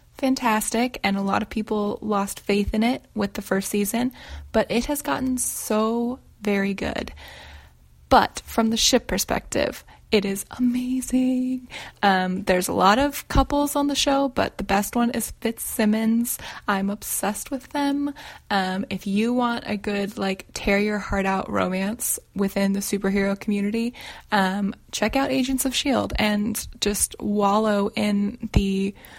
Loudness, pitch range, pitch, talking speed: -23 LUFS, 200-245 Hz, 210 Hz, 155 wpm